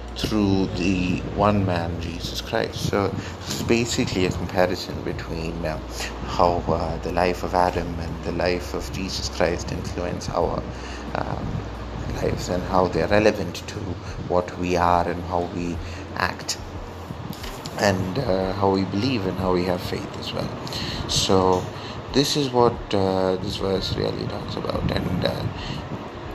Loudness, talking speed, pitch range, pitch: -24 LUFS, 150 wpm, 85-100 Hz, 90 Hz